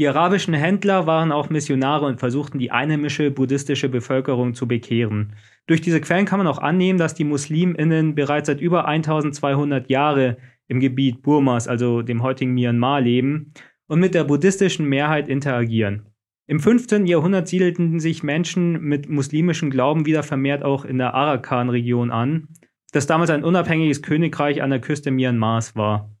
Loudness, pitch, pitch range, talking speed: -20 LUFS, 145 Hz, 130-160 Hz, 160 wpm